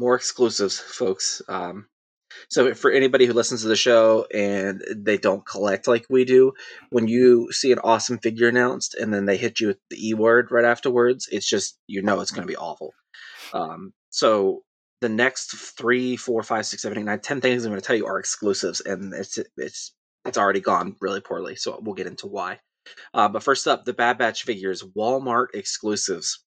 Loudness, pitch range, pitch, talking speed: -22 LUFS, 110-125 Hz, 120 Hz, 200 wpm